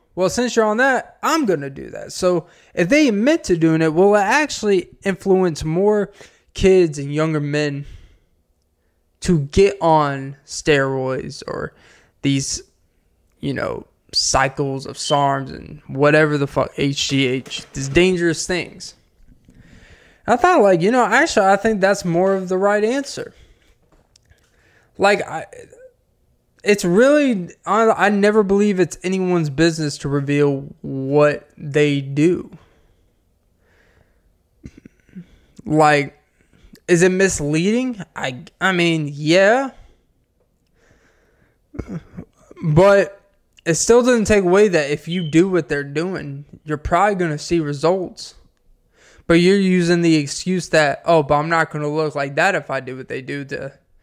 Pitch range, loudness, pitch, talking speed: 145-195 Hz, -17 LUFS, 165 Hz, 135 wpm